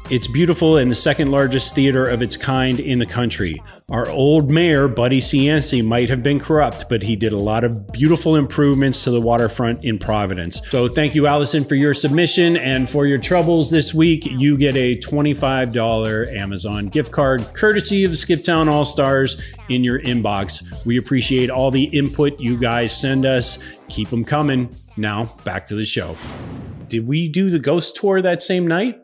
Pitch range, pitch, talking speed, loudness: 115-150 Hz, 135 Hz, 185 wpm, -17 LUFS